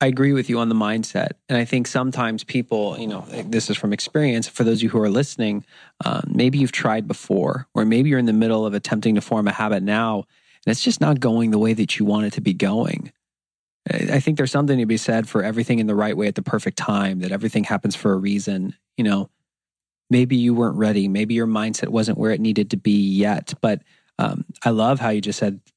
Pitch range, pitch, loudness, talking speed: 105-125 Hz, 110 Hz, -21 LUFS, 240 wpm